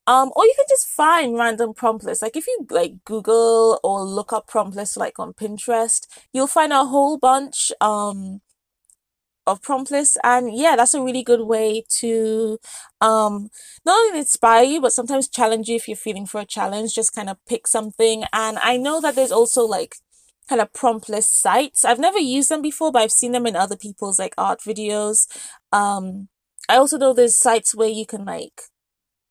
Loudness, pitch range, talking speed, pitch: -18 LUFS, 215-265 Hz, 195 wpm, 230 Hz